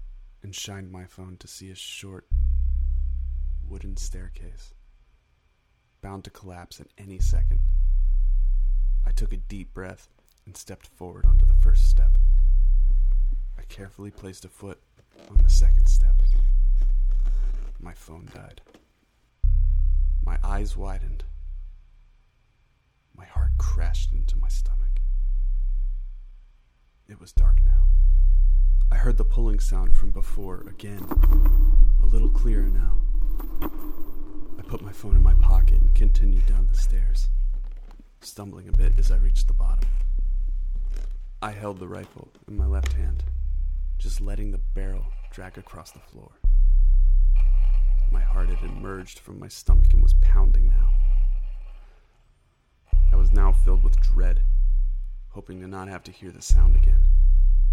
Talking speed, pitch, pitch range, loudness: 135 wpm, 70 Hz, 65-95 Hz, -25 LUFS